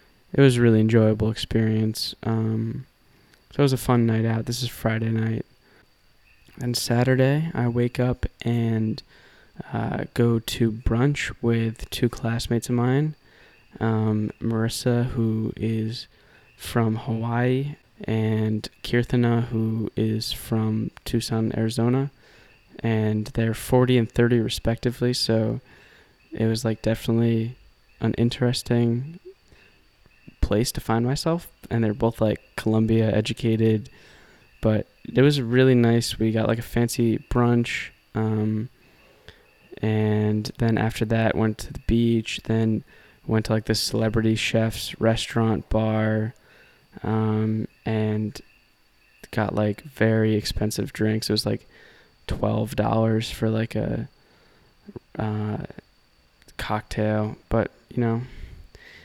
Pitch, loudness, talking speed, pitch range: 110 Hz, -24 LUFS, 120 wpm, 110-120 Hz